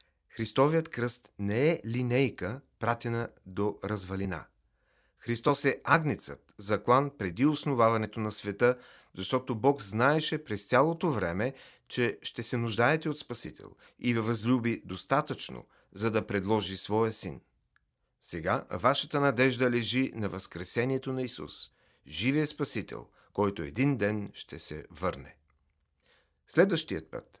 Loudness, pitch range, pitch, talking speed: -30 LUFS, 100-130 Hz, 115 Hz, 120 wpm